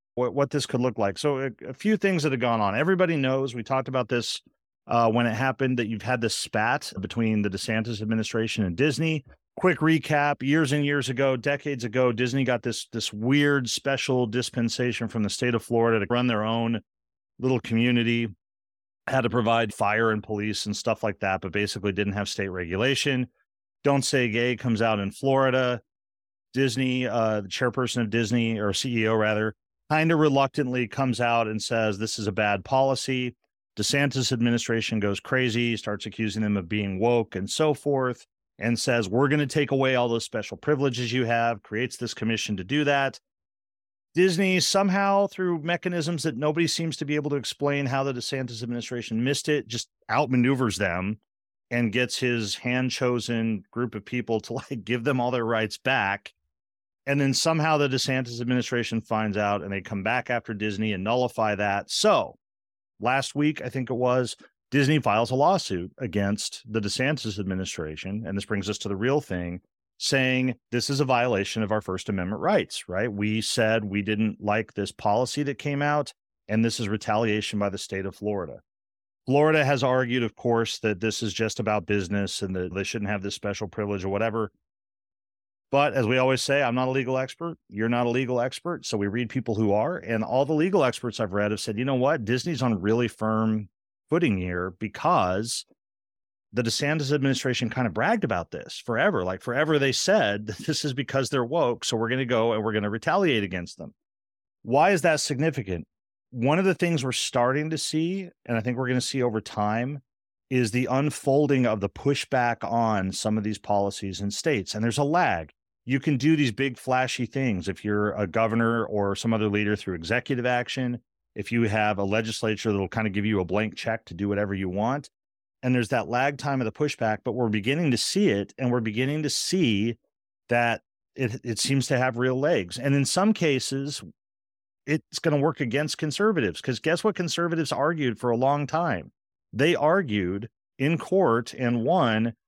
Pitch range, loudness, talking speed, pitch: 105-135 Hz, -25 LUFS, 195 wpm, 120 Hz